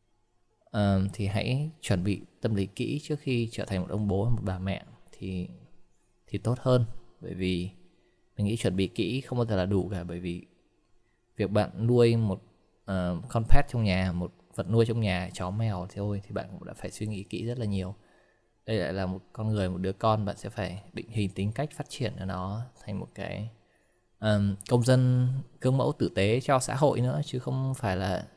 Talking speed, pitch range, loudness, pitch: 220 wpm, 95-120 Hz, -30 LUFS, 105 Hz